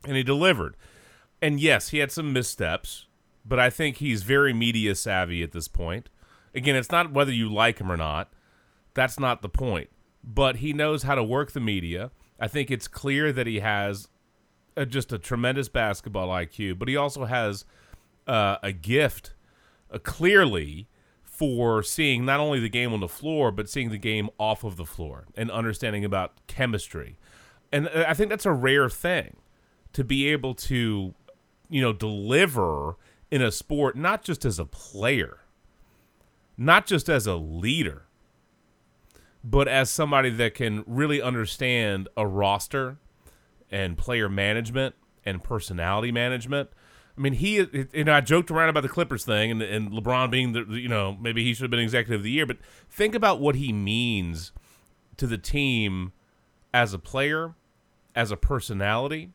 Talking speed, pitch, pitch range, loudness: 165 wpm, 120 Hz, 105-140 Hz, -25 LUFS